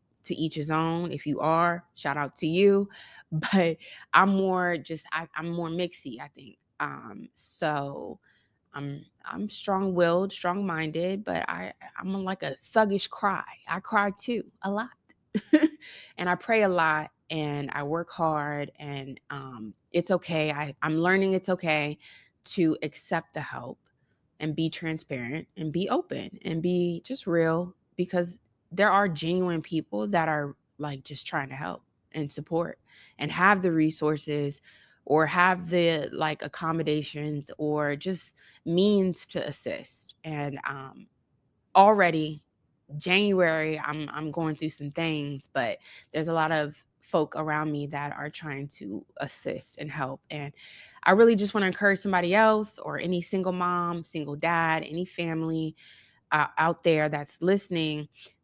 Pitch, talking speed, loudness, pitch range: 160 Hz, 150 wpm, -28 LUFS, 150-180 Hz